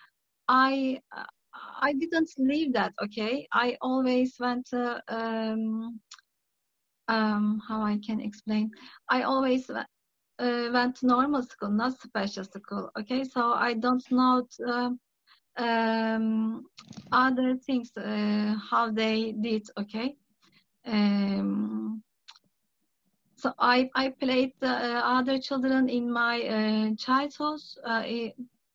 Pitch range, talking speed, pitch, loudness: 215-255 Hz, 115 wpm, 240 Hz, -28 LUFS